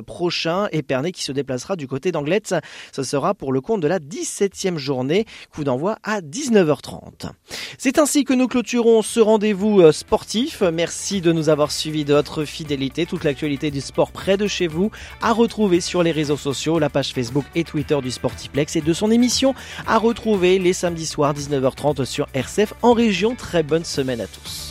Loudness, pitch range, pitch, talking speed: -20 LUFS, 145-210 Hz, 170 Hz, 190 wpm